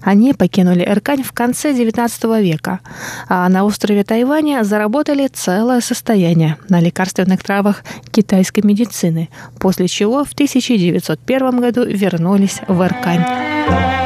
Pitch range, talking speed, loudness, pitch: 185-245 Hz, 115 wpm, -15 LUFS, 205 Hz